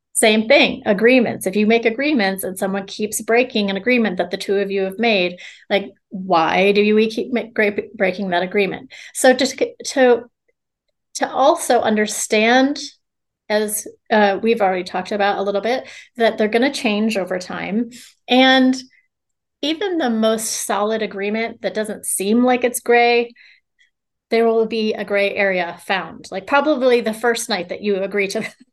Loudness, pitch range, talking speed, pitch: -18 LUFS, 200-250 Hz, 165 wpm, 220 Hz